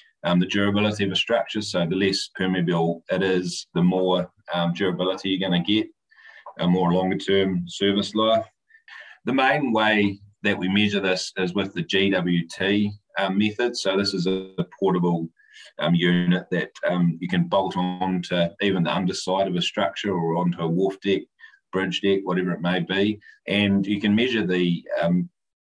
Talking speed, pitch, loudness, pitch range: 180 wpm, 95 Hz, -23 LUFS, 90-100 Hz